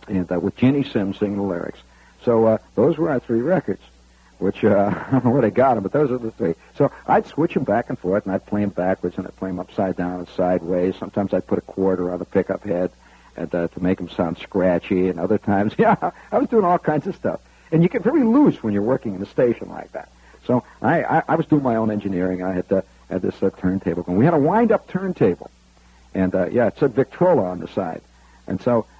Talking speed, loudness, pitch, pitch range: 255 wpm, -21 LUFS, 95 Hz, 90-120 Hz